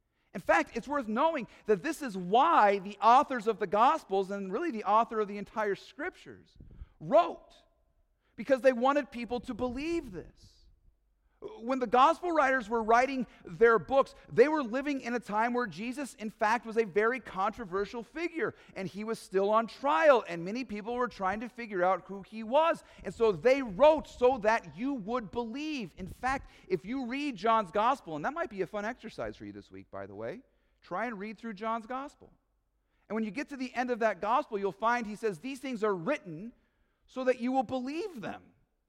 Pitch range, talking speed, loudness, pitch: 210-265 Hz, 200 wpm, -30 LUFS, 235 Hz